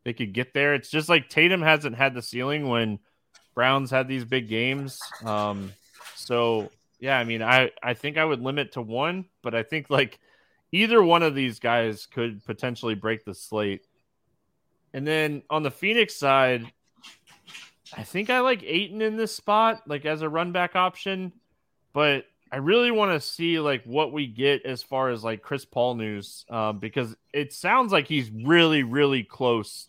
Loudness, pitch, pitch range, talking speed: -24 LUFS, 135 Hz, 120-160 Hz, 185 wpm